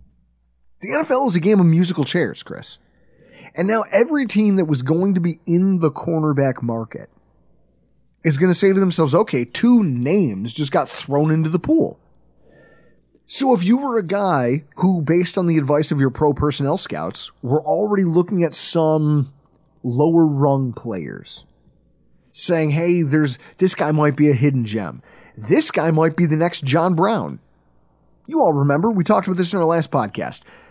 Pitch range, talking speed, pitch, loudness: 140-185 Hz, 175 wpm, 160 Hz, -18 LUFS